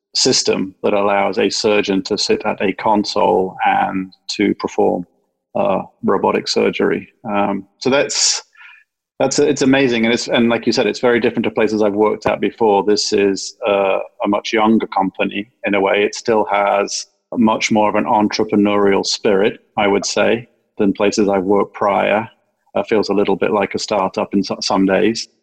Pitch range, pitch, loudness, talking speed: 100-115 Hz, 105 Hz, -16 LUFS, 180 wpm